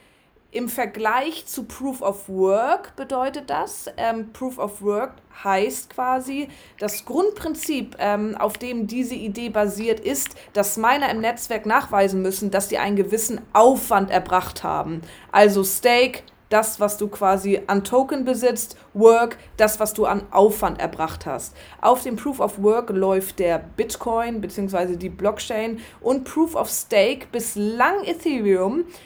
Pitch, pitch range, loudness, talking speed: 220 Hz, 200-250 Hz, -21 LUFS, 145 wpm